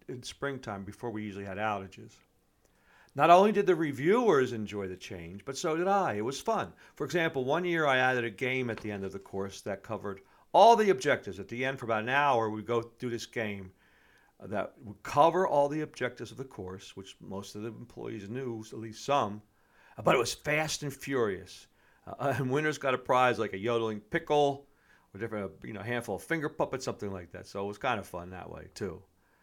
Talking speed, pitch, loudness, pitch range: 220 wpm, 120 Hz, -30 LUFS, 105-140 Hz